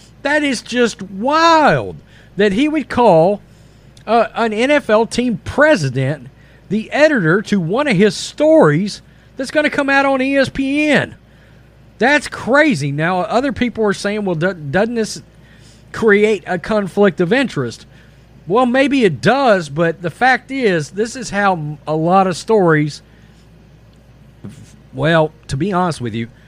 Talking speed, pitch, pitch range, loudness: 145 wpm, 210 Hz, 165-255 Hz, -15 LUFS